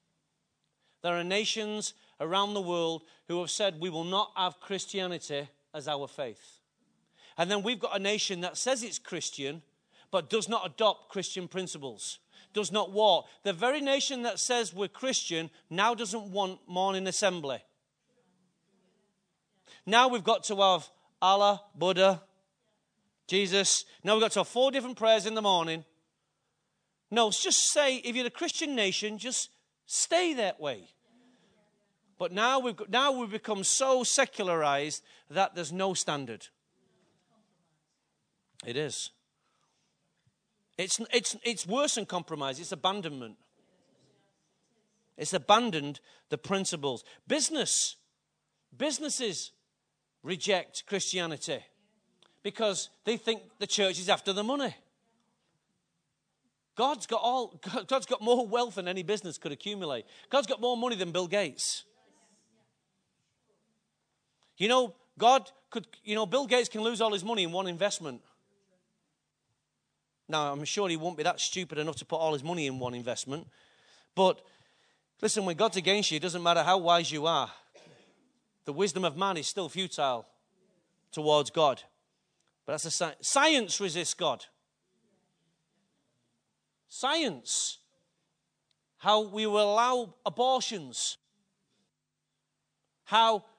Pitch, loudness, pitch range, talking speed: 195 Hz, -29 LUFS, 175-225 Hz, 135 wpm